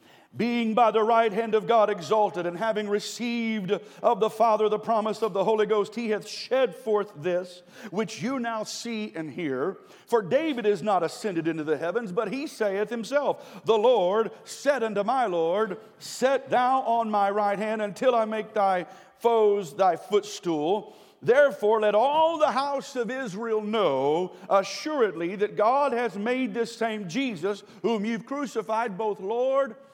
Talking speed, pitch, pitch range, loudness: 165 wpm, 220 Hz, 205-240 Hz, -26 LUFS